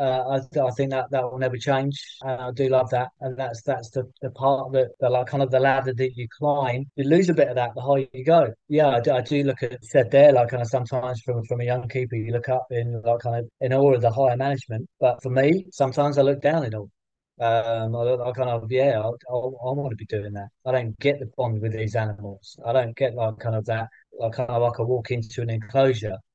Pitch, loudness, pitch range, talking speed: 125 Hz, -23 LUFS, 115-135 Hz, 265 wpm